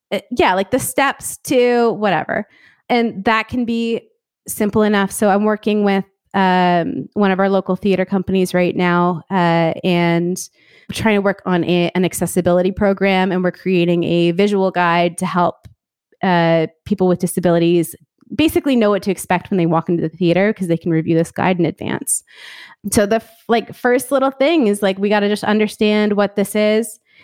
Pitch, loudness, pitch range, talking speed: 195 Hz, -17 LUFS, 175-215 Hz, 185 wpm